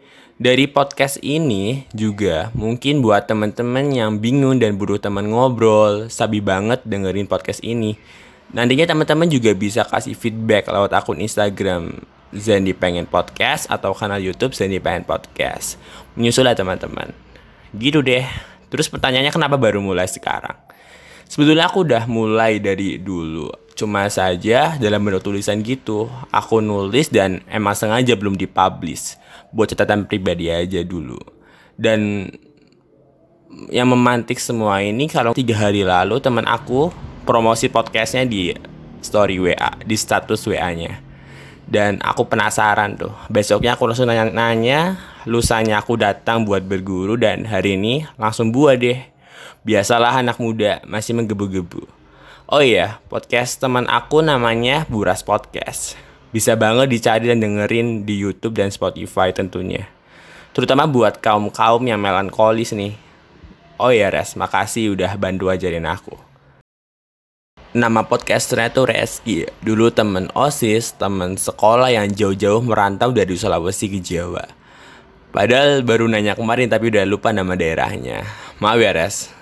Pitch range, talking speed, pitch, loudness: 100-120 Hz, 135 wpm, 110 Hz, -17 LUFS